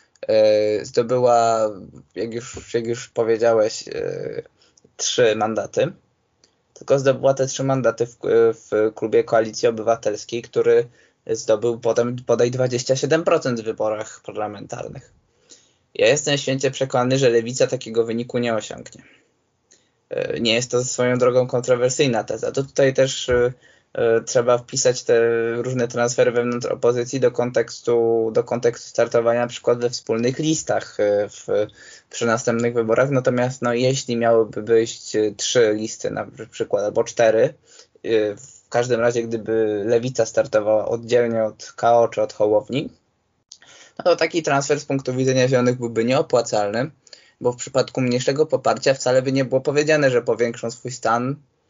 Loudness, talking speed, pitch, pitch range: -20 LUFS, 130 wpm, 125 Hz, 115-140 Hz